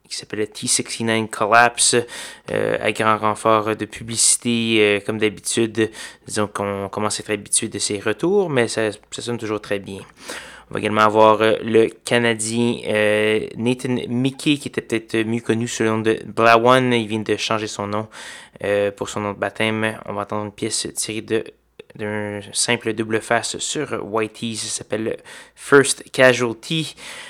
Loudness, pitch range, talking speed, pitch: -19 LUFS, 105-120 Hz, 170 wpm, 110 Hz